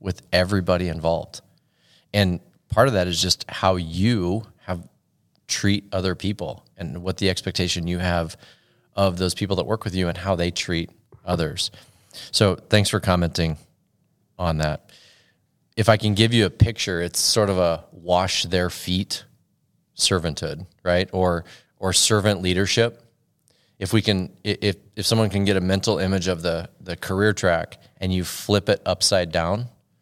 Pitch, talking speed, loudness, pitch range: 95 Hz, 160 wpm, -22 LUFS, 90-105 Hz